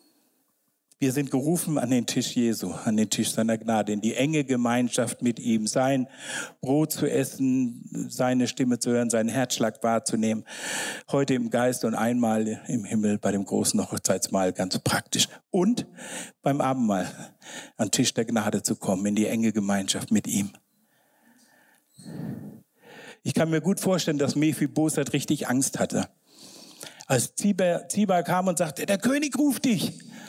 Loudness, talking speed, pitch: -26 LUFS, 155 wpm, 135 Hz